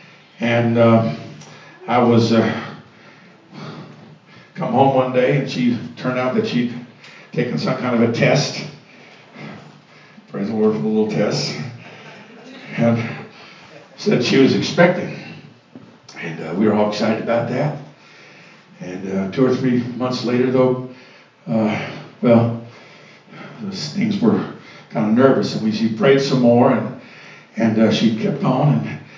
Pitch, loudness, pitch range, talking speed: 125 Hz, -18 LUFS, 115-135 Hz, 145 wpm